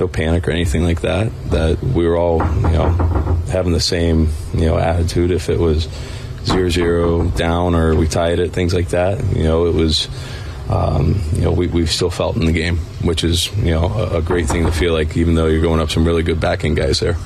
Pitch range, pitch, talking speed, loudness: 80-90 Hz, 85 Hz, 230 wpm, -17 LUFS